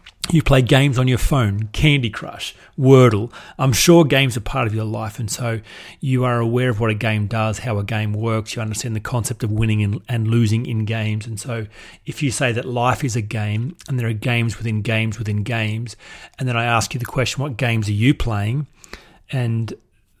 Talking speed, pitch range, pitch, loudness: 215 wpm, 110-130 Hz, 115 Hz, -19 LUFS